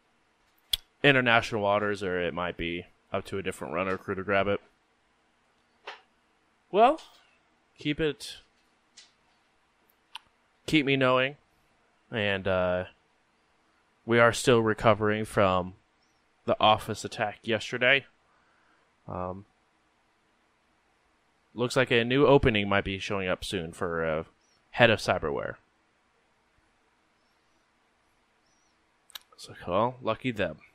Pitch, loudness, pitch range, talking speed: 100 Hz, -27 LUFS, 90-115 Hz, 100 wpm